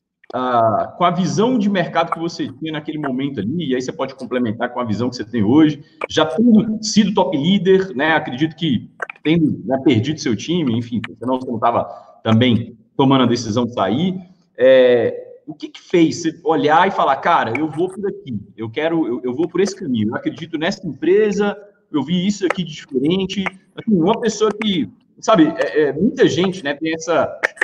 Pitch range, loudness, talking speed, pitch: 150-205 Hz, -18 LUFS, 200 wpm, 170 Hz